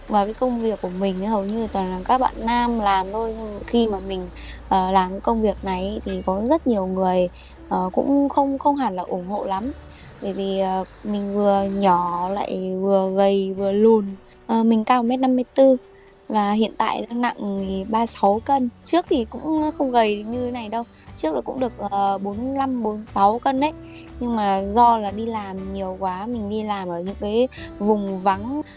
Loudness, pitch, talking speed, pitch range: -22 LUFS, 210 Hz, 200 wpm, 195-240 Hz